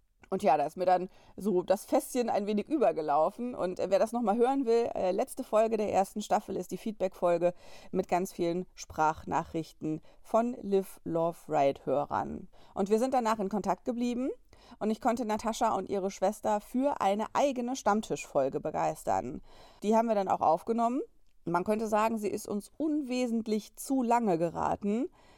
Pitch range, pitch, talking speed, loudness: 185-240 Hz, 210 Hz, 165 wpm, -31 LUFS